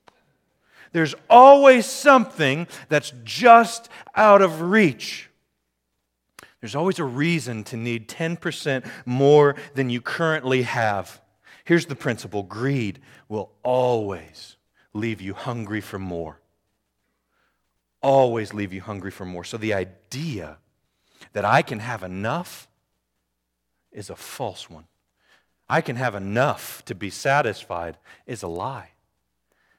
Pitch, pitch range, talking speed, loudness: 120 Hz, 95-150 Hz, 120 wpm, -20 LUFS